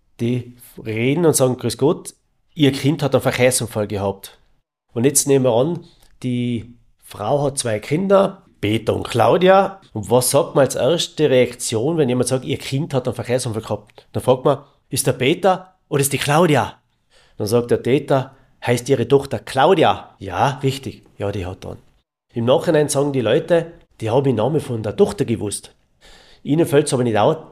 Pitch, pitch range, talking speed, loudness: 130 Hz, 120-145 Hz, 185 wpm, -18 LUFS